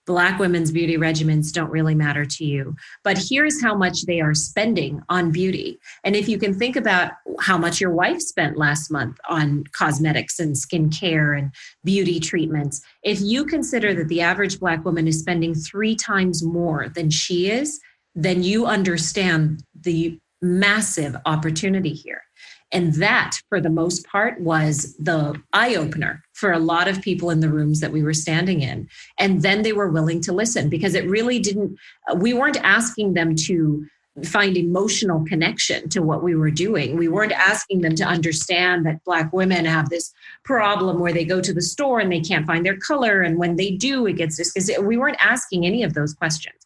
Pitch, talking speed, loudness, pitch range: 175 Hz, 190 wpm, -20 LUFS, 160-195 Hz